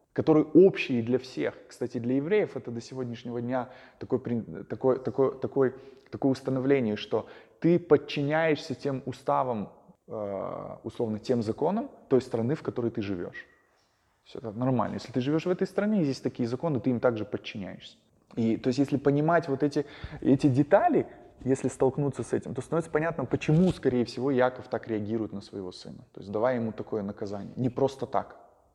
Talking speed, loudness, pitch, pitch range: 170 wpm, -28 LUFS, 130 Hz, 120-145 Hz